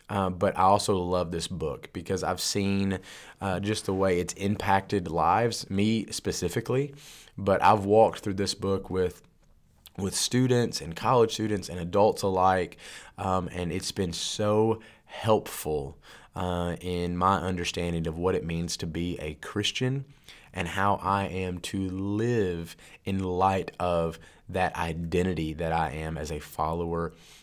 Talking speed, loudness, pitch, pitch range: 150 wpm, -28 LUFS, 95 Hz, 85-100 Hz